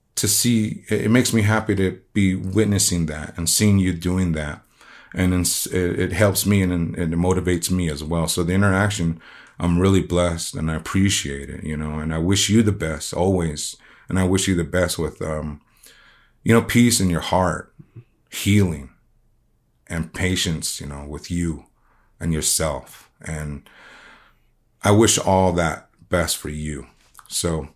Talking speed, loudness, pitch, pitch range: 165 wpm, -20 LUFS, 90 Hz, 80-95 Hz